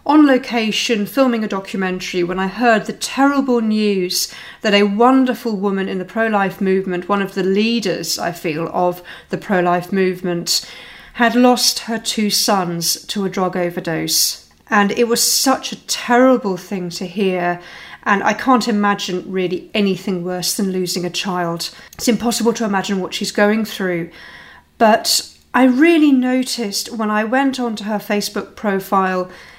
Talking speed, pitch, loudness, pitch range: 160 wpm, 200 Hz, -17 LUFS, 180-235 Hz